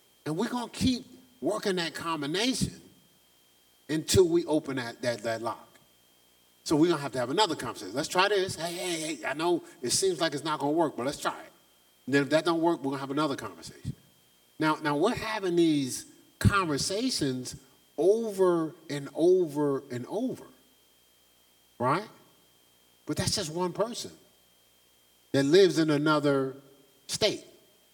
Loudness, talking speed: -28 LUFS, 160 wpm